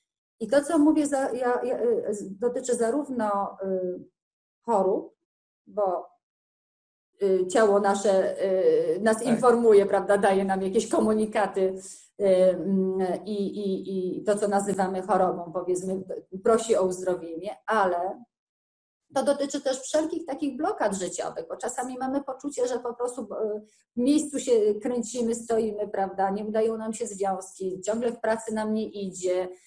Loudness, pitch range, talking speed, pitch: -26 LUFS, 190-255 Hz, 125 wpm, 215 Hz